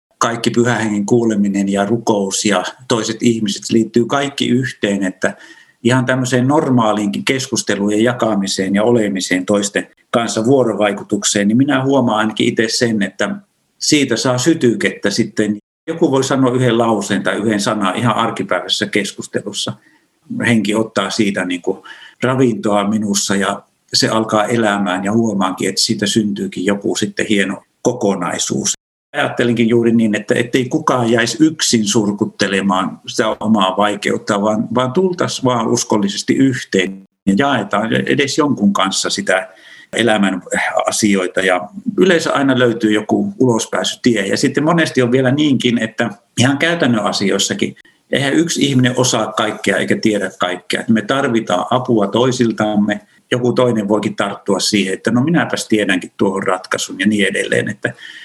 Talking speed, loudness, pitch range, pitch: 135 wpm, -15 LUFS, 100-125 Hz, 110 Hz